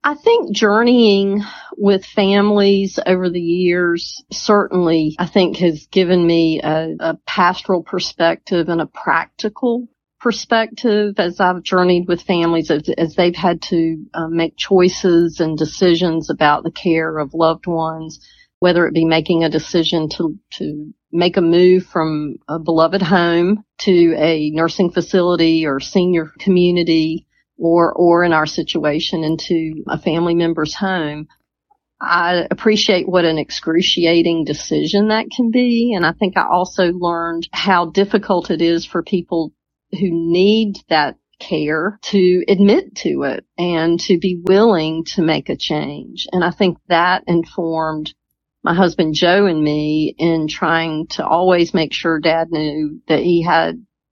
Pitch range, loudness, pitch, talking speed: 165-185 Hz, -16 LUFS, 175 Hz, 145 wpm